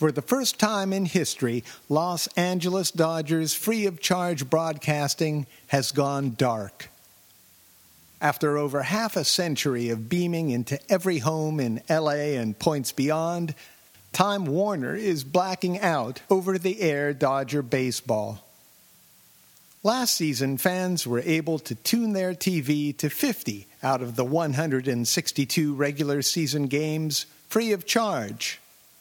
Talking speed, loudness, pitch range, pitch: 130 wpm, -25 LUFS, 140-180 Hz, 155 Hz